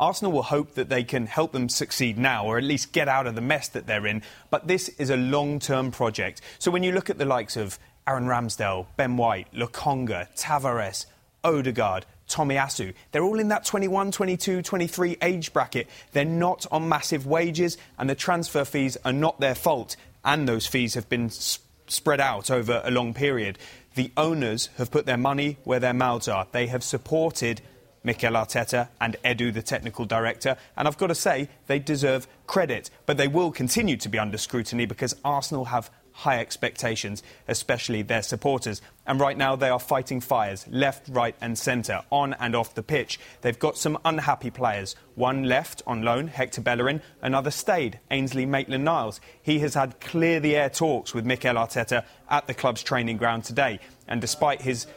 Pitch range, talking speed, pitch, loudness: 120-145 Hz, 190 wpm, 130 Hz, -26 LUFS